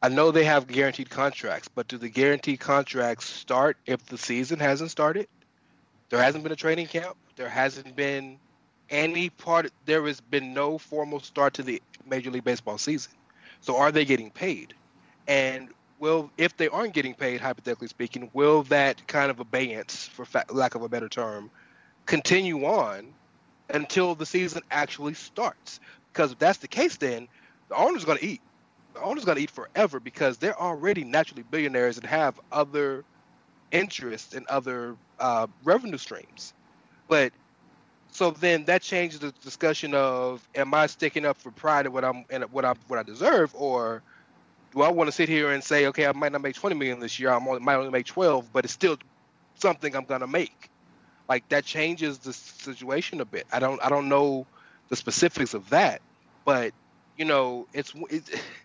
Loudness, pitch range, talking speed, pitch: -26 LUFS, 130-155 Hz, 185 wpm, 140 Hz